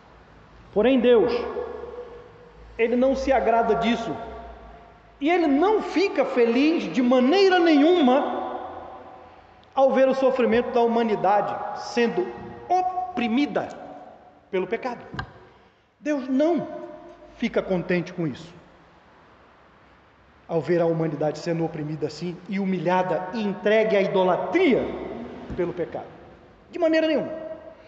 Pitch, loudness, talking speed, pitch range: 245 Hz, -23 LUFS, 105 wpm, 200-315 Hz